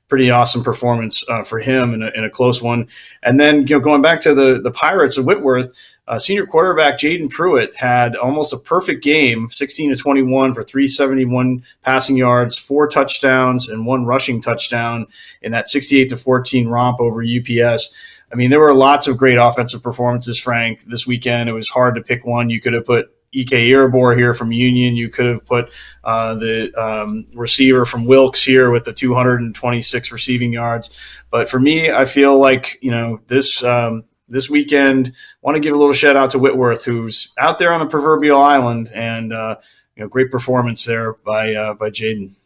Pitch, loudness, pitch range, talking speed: 125 Hz, -14 LUFS, 115-135 Hz, 195 wpm